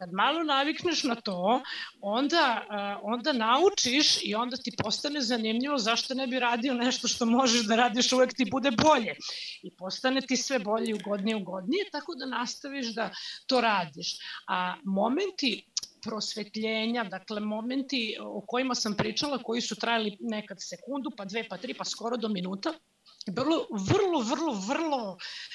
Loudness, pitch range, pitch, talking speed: -28 LUFS, 215-270 Hz, 240 Hz, 155 wpm